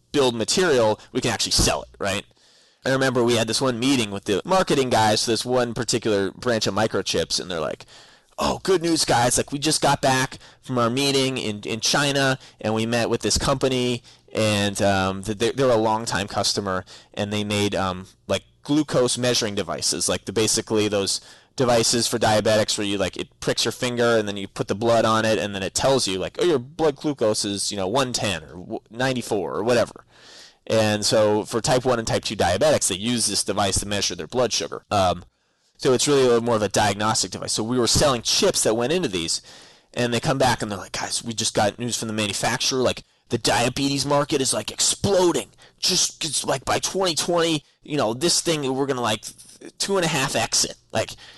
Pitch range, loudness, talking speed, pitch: 105-130 Hz, -22 LUFS, 215 wpm, 115 Hz